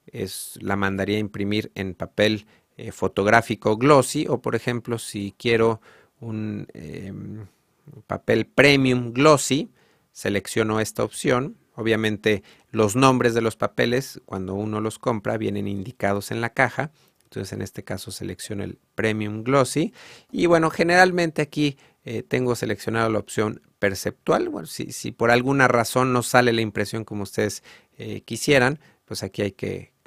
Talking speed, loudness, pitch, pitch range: 150 wpm, -22 LUFS, 115 Hz, 105-130 Hz